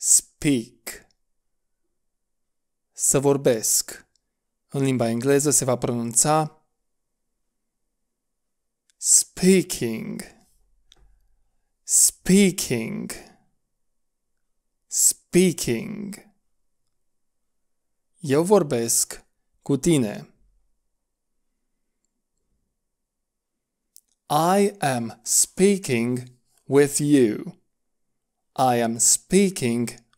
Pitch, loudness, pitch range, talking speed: 145 Hz, -20 LUFS, 120-185 Hz, 50 wpm